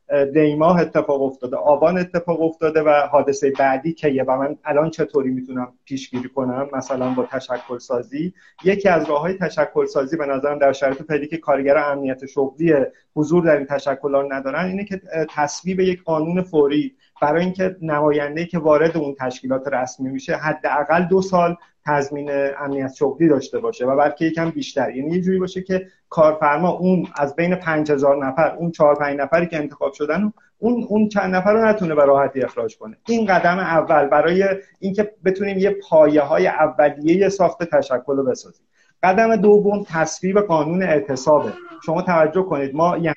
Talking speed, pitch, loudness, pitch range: 170 wpm, 155 Hz, -19 LUFS, 140-180 Hz